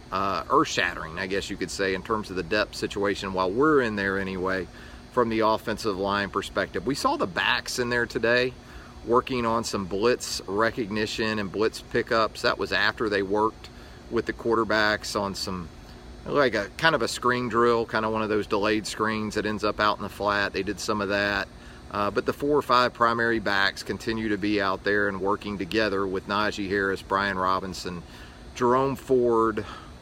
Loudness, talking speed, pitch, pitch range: -25 LUFS, 195 wpm, 105 Hz, 95-115 Hz